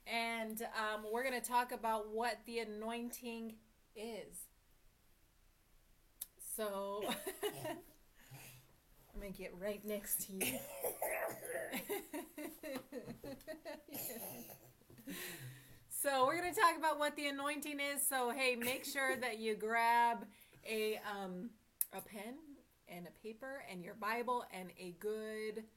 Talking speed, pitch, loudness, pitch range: 120 wpm, 230 Hz, -40 LUFS, 210-270 Hz